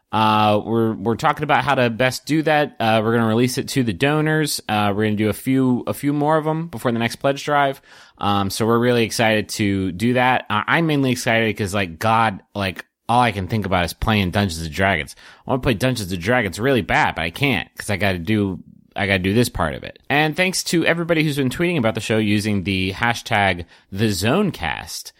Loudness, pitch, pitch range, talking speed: -19 LUFS, 115 Hz, 100-130 Hz, 230 wpm